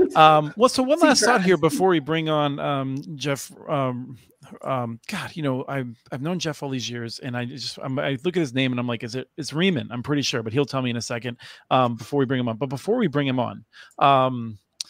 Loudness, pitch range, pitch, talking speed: -23 LUFS, 125-155 Hz, 135 Hz, 260 wpm